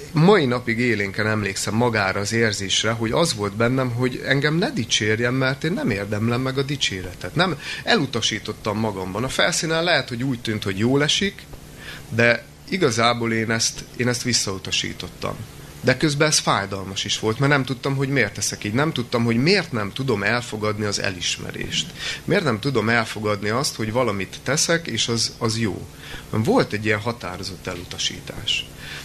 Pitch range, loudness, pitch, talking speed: 105-135 Hz, -21 LUFS, 115 Hz, 165 wpm